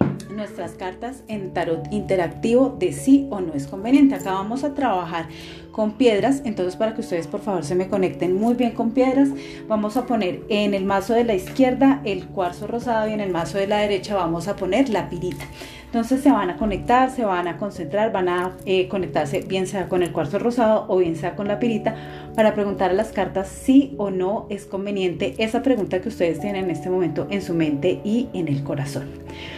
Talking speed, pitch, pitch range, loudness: 215 wpm, 200 Hz, 180-230 Hz, -22 LUFS